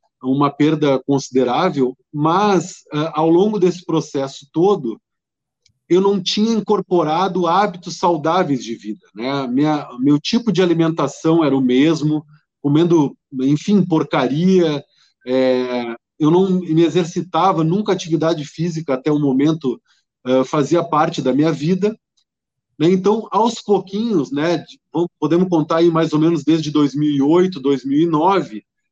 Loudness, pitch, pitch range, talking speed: -17 LUFS, 160 Hz, 140-180 Hz, 125 wpm